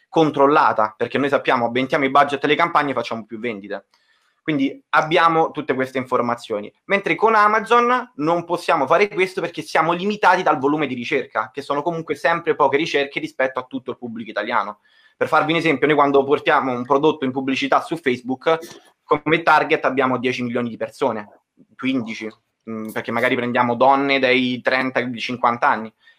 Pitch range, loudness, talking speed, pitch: 125-165 Hz, -19 LUFS, 165 wpm, 140 Hz